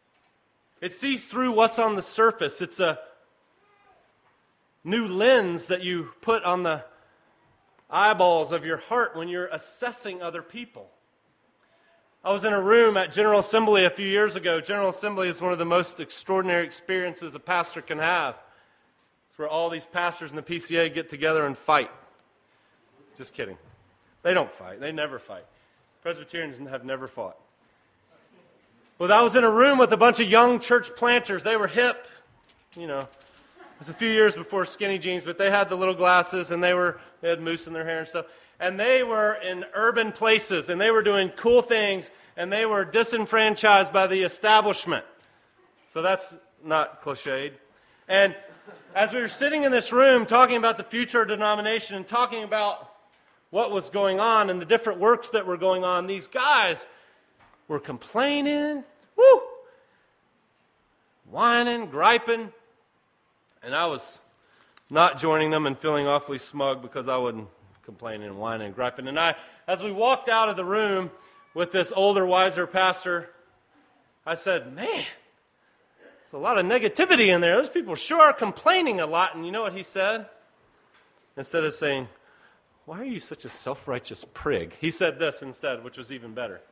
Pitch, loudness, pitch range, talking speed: 190 Hz, -23 LUFS, 165-225 Hz, 175 wpm